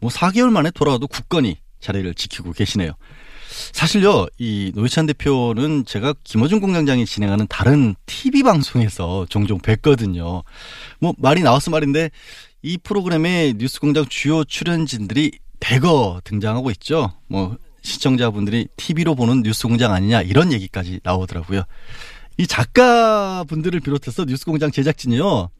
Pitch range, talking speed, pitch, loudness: 105-155 Hz, 335 characters per minute, 130 Hz, -18 LUFS